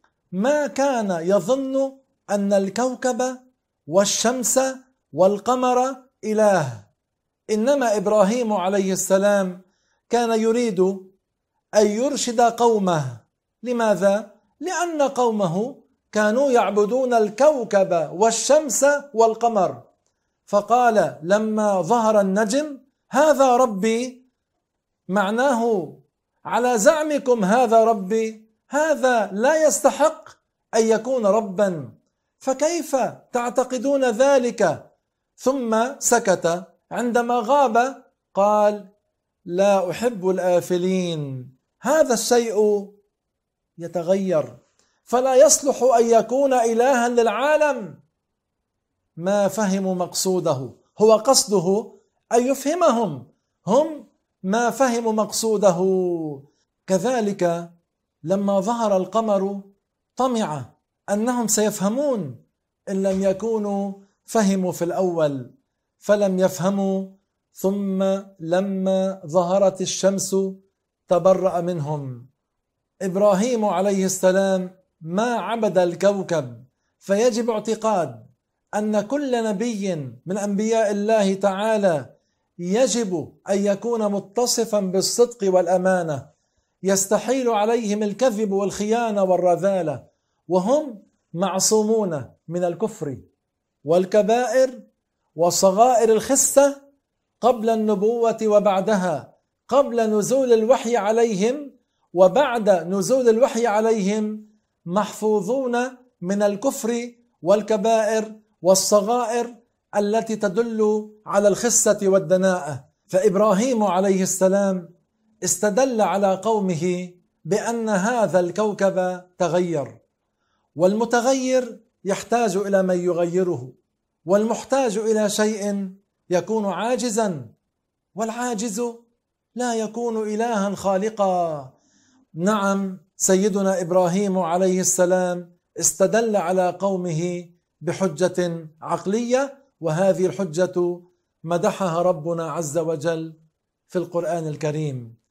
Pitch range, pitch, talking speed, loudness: 185-235 Hz, 205 Hz, 80 wpm, -21 LUFS